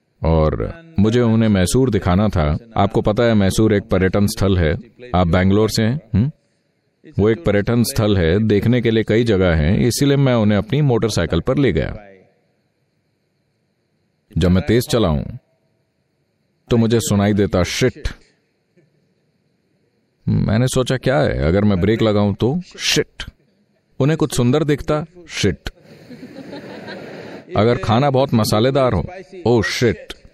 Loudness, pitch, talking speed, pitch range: -17 LUFS, 110 Hz, 135 wpm, 100-125 Hz